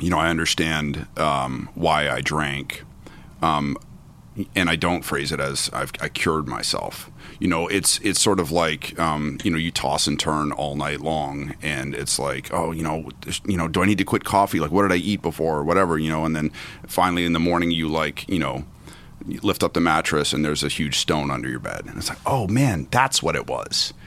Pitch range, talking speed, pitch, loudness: 75-85 Hz, 230 wpm, 80 Hz, -22 LUFS